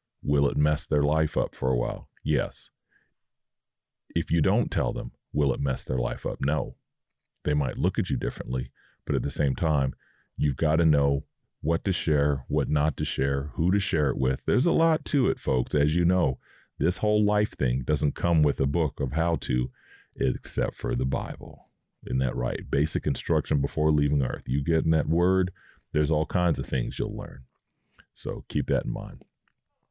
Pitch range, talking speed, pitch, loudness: 70-85 Hz, 200 wpm, 75 Hz, -27 LUFS